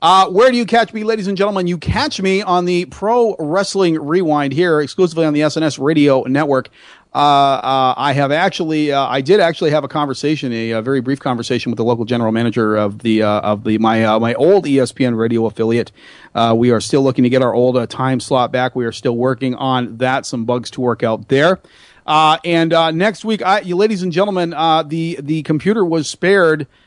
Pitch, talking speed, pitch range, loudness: 140 Hz, 220 wpm, 125-175 Hz, -15 LUFS